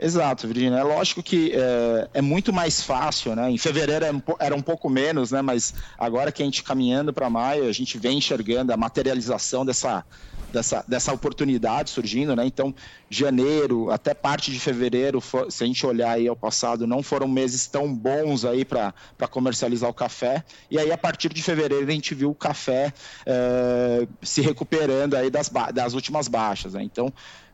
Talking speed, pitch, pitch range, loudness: 180 wpm, 130 Hz, 125-145 Hz, -24 LUFS